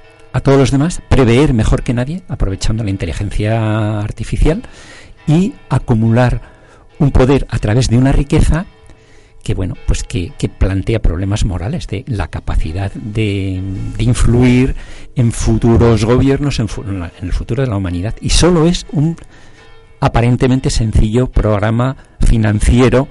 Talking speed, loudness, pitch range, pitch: 140 wpm, -14 LUFS, 105-130 Hz, 115 Hz